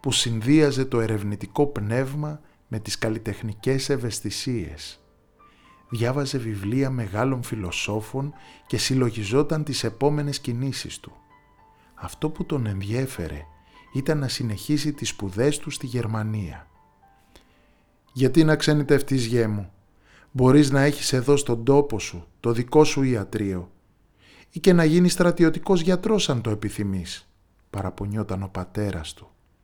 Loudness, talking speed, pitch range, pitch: -24 LUFS, 120 wpm, 100-145 Hz, 120 Hz